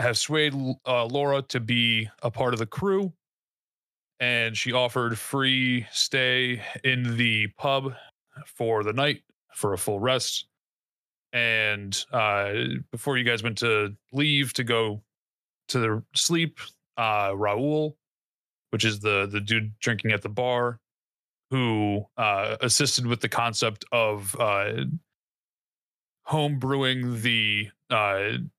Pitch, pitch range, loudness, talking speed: 120 Hz, 110-135 Hz, -25 LUFS, 130 wpm